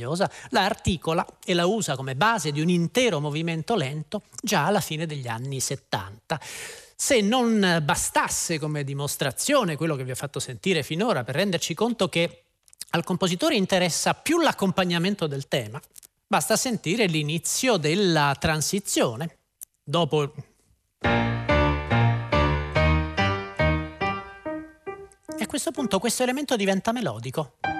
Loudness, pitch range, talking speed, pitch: -24 LUFS, 140-205 Hz, 120 wpm, 165 Hz